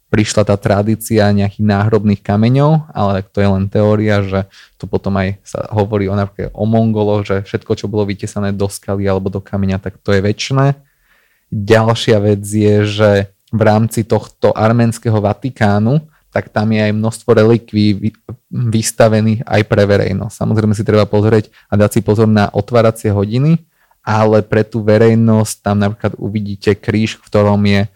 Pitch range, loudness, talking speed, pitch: 100-110 Hz, -14 LUFS, 160 wpm, 105 Hz